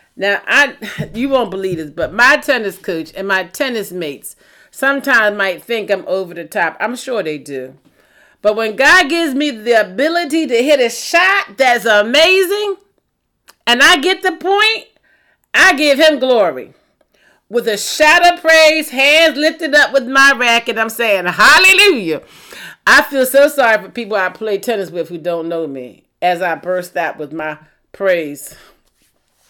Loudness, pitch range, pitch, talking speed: -12 LUFS, 190-300 Hz, 235 Hz, 165 wpm